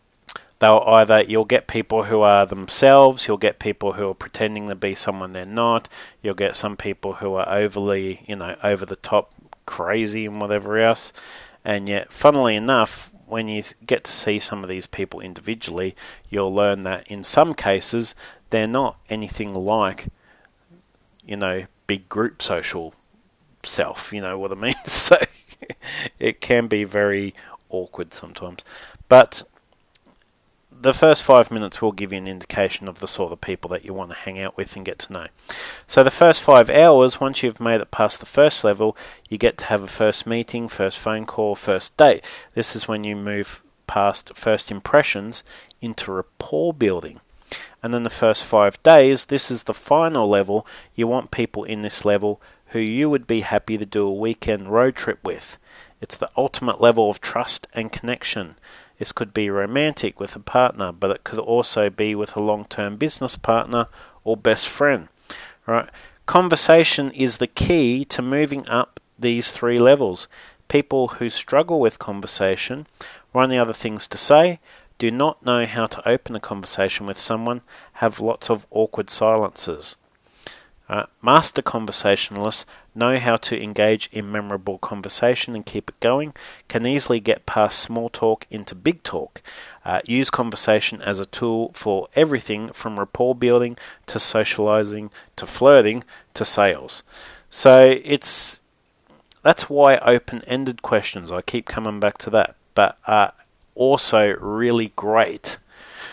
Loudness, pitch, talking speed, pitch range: -19 LUFS, 110 Hz, 165 wpm, 105-120 Hz